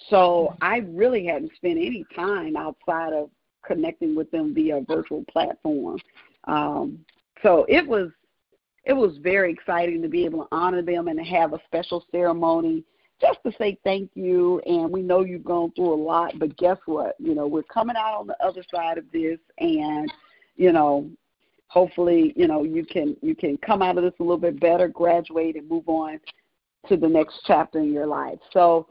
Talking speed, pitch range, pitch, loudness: 195 wpm, 165-205 Hz, 175 Hz, -23 LUFS